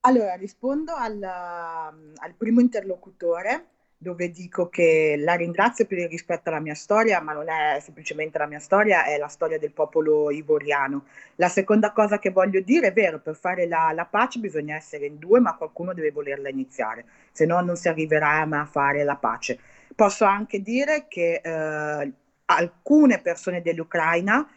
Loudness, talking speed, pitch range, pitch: -23 LUFS, 170 wpm, 155-205 Hz, 170 Hz